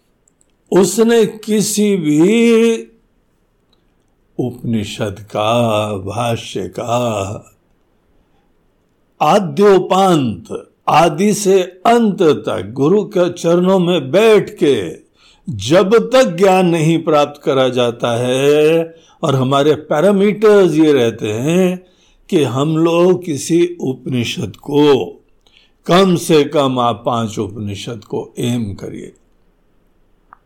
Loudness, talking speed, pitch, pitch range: -14 LUFS, 95 wpm, 155 Hz, 120-190 Hz